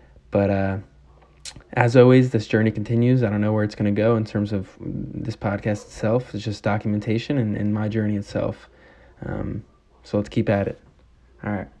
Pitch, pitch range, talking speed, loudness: 105 Hz, 100-115 Hz, 190 wpm, -22 LUFS